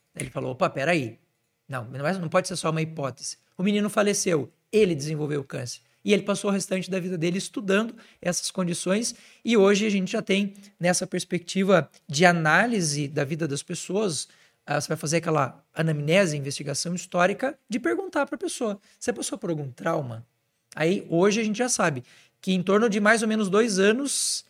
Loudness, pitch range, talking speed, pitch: -25 LUFS, 155-210 Hz, 185 wpm, 180 Hz